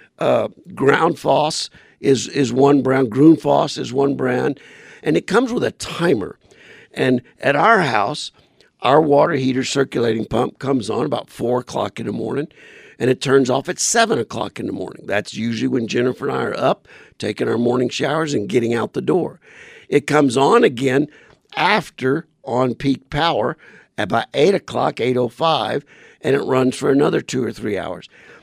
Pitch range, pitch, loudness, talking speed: 125-145 Hz, 130 Hz, -18 LUFS, 175 wpm